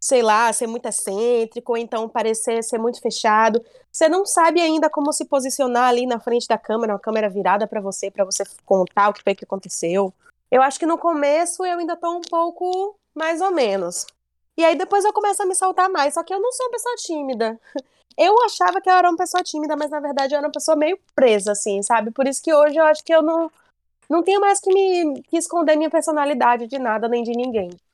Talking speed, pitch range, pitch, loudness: 230 wpm, 225-340 Hz, 290 Hz, -19 LUFS